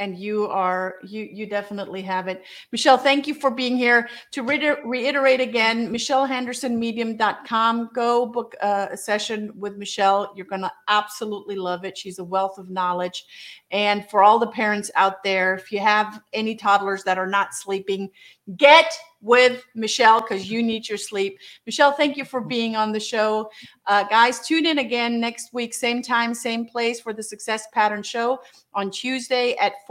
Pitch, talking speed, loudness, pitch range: 220 Hz, 175 wpm, -21 LUFS, 200-245 Hz